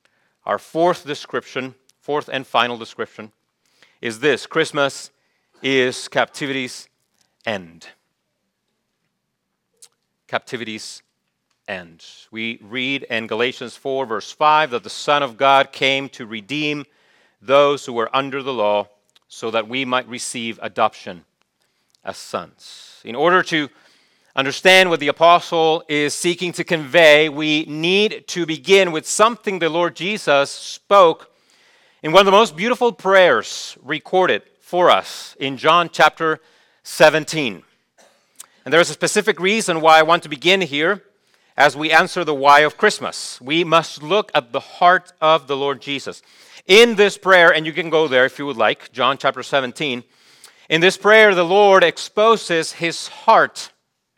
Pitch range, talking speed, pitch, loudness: 135-175 Hz, 145 wpm, 155 Hz, -17 LUFS